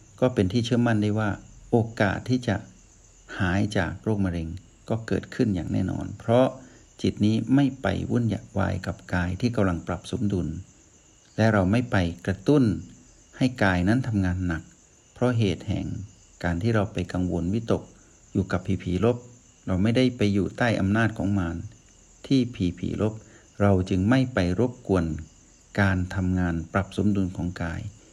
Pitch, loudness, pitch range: 100 Hz, -25 LUFS, 90-115 Hz